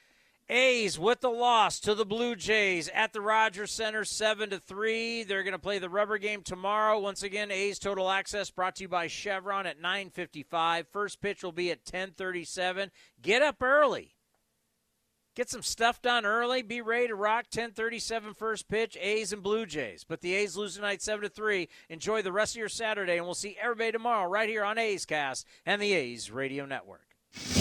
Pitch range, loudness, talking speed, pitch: 185-220 Hz, -30 LUFS, 185 wpm, 205 Hz